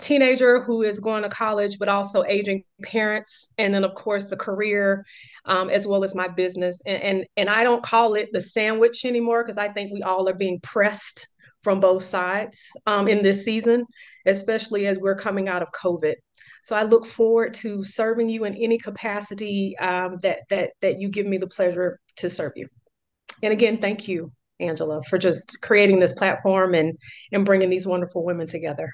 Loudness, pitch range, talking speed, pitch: -22 LUFS, 185-220 Hz, 195 wpm, 200 Hz